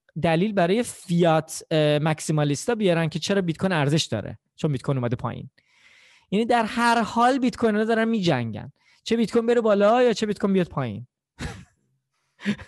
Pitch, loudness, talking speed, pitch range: 175 Hz, -23 LUFS, 165 wpm, 150-225 Hz